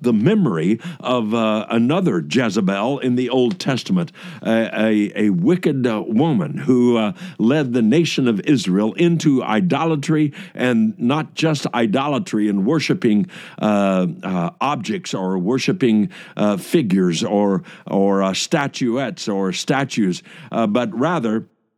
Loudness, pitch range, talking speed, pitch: -19 LUFS, 105-165 Hz, 125 wpm, 125 Hz